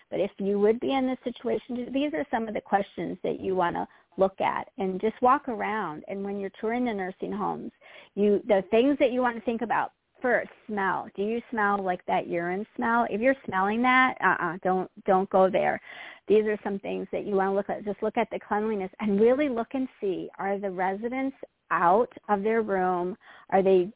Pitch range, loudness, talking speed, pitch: 190-235 Hz, -27 LUFS, 220 wpm, 210 Hz